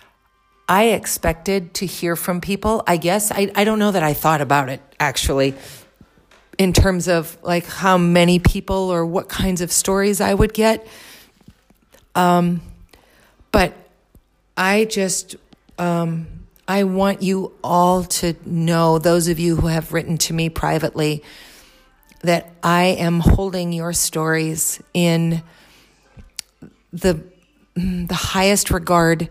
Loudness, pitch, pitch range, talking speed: -18 LUFS, 175 Hz, 165-190 Hz, 130 wpm